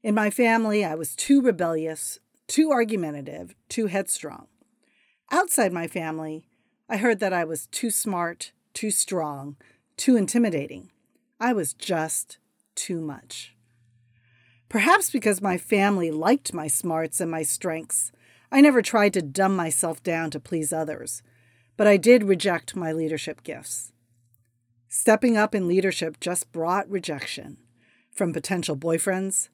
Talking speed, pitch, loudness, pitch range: 135 wpm, 170 Hz, -24 LUFS, 150-210 Hz